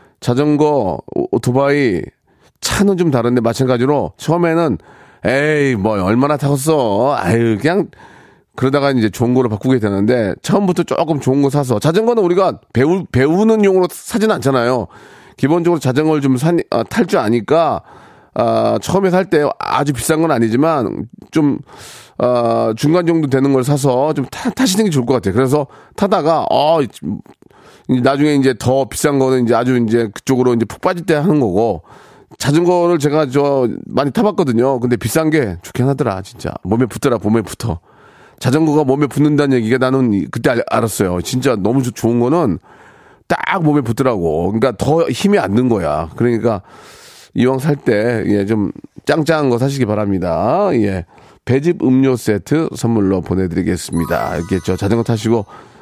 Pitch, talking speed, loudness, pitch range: 130 Hz, 330 characters per minute, -15 LUFS, 115-150 Hz